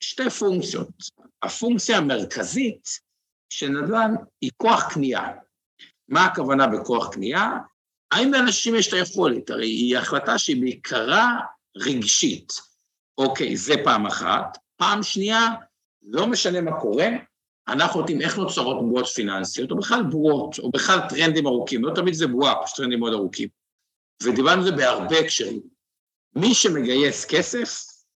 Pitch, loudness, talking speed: 180 Hz, -22 LUFS, 135 wpm